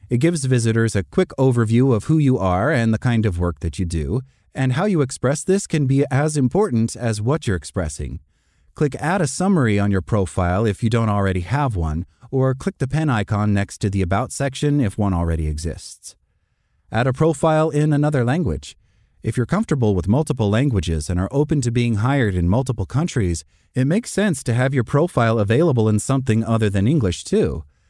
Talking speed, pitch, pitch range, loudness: 200 wpm, 115 Hz, 95-140 Hz, -20 LUFS